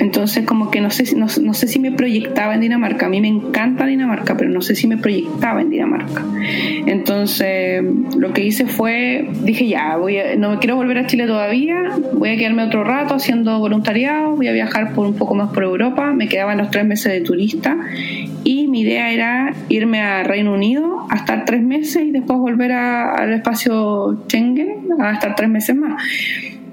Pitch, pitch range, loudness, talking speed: 235 Hz, 210-270 Hz, -16 LUFS, 200 wpm